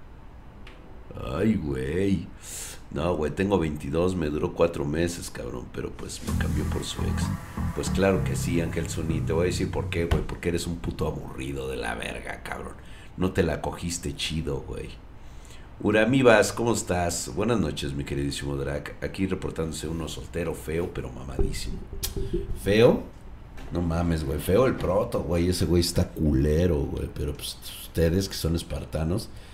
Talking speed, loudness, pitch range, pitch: 160 wpm, -27 LUFS, 75-90 Hz, 85 Hz